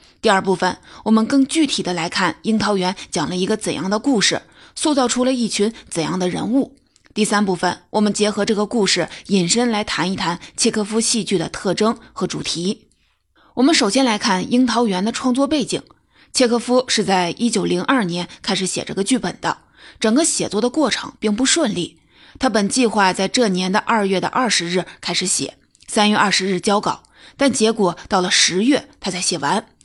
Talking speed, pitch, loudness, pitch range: 285 characters per minute, 210 Hz, -18 LUFS, 185-240 Hz